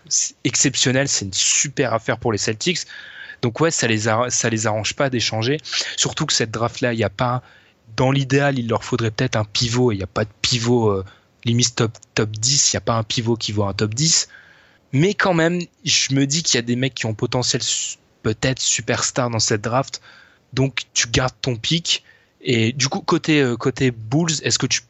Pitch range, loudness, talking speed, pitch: 115-140 Hz, -19 LUFS, 220 wpm, 125 Hz